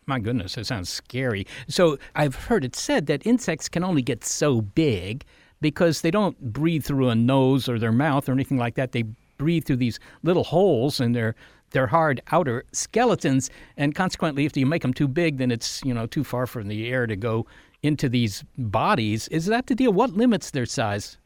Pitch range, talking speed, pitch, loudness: 120-160 Hz, 205 wpm, 135 Hz, -24 LUFS